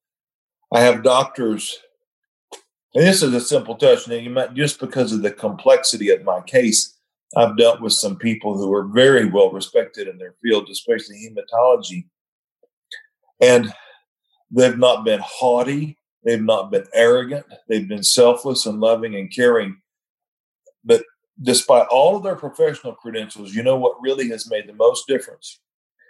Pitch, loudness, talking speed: 135 Hz, -17 LUFS, 155 wpm